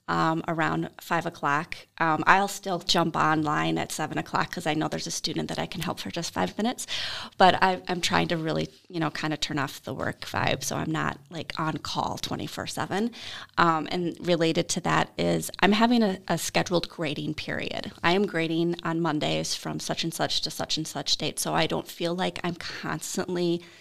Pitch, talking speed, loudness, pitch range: 170 Hz, 205 wpm, -27 LUFS, 155-185 Hz